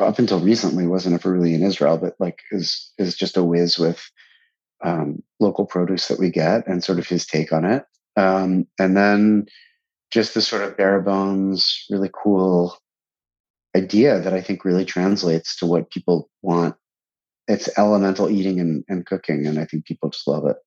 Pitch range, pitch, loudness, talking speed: 85-100 Hz, 95 Hz, -20 LUFS, 185 wpm